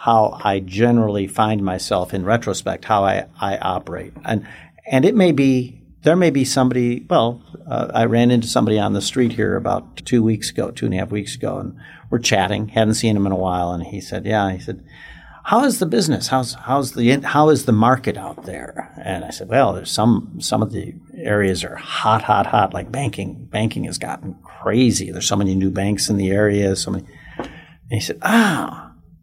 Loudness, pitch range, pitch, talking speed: -19 LUFS, 95-125 Hz, 110 Hz, 210 wpm